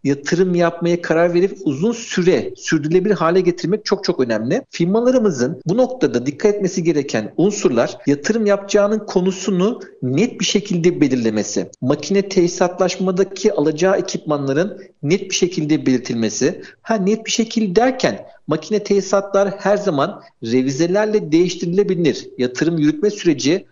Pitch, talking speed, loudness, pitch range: 185 Hz, 120 wpm, -18 LUFS, 155-205 Hz